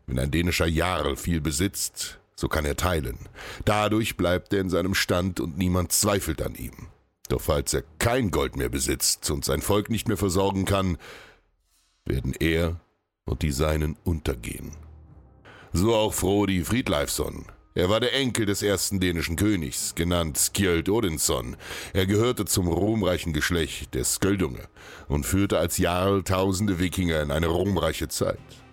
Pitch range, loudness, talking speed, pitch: 80-100 Hz, -25 LUFS, 150 wpm, 90 Hz